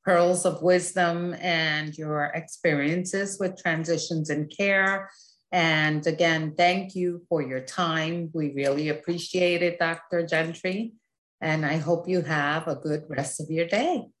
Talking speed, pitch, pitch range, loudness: 145 wpm, 170 Hz, 155-180 Hz, -26 LUFS